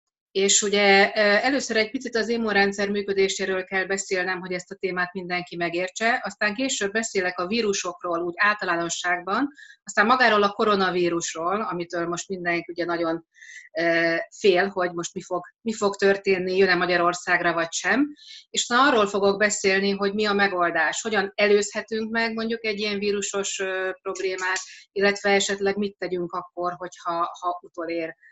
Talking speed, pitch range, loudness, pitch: 150 wpm, 180-210 Hz, -23 LUFS, 195 Hz